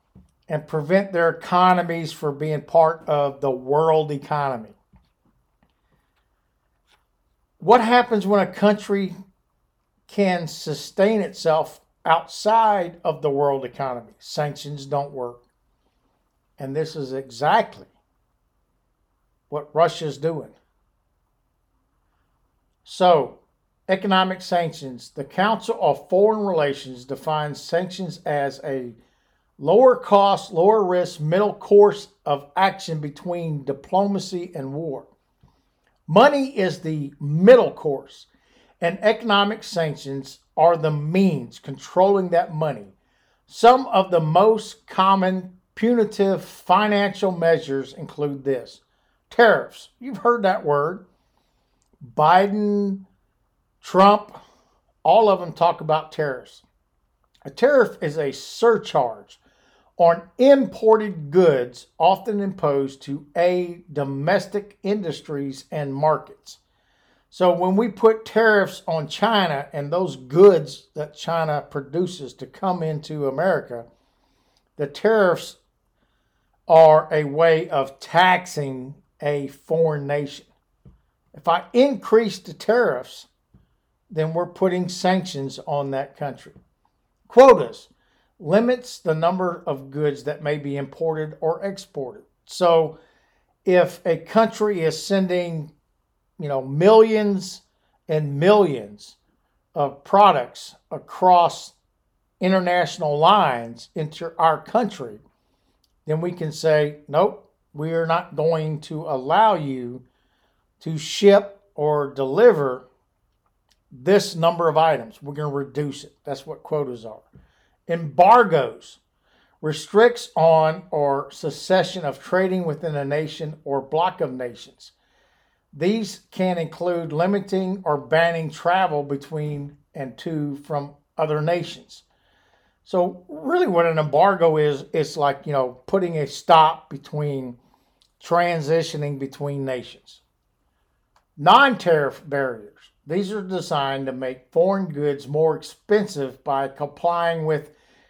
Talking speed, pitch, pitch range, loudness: 110 wpm, 160 Hz, 145-190 Hz, -20 LUFS